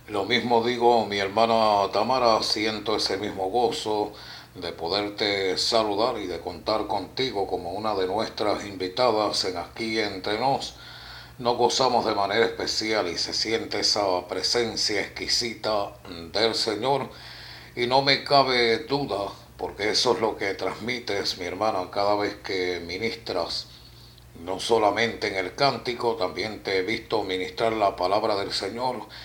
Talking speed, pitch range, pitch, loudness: 145 wpm, 100-120 Hz, 110 Hz, -25 LUFS